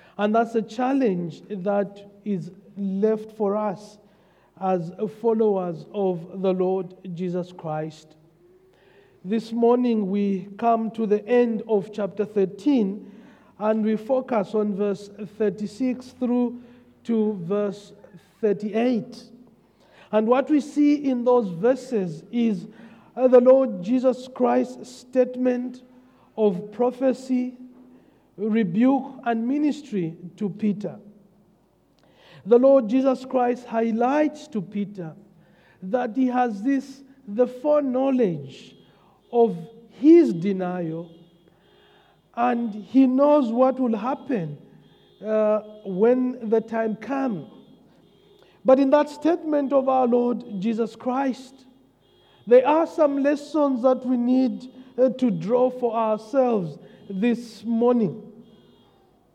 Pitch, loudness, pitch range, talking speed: 225 Hz, -23 LUFS, 200-255 Hz, 105 wpm